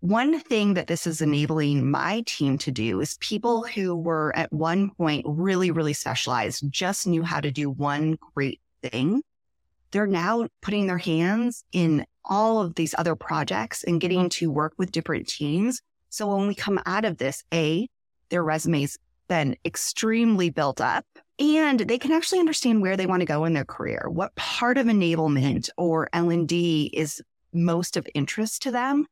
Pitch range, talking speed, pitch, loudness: 155-215 Hz, 175 wpm, 175 Hz, -25 LUFS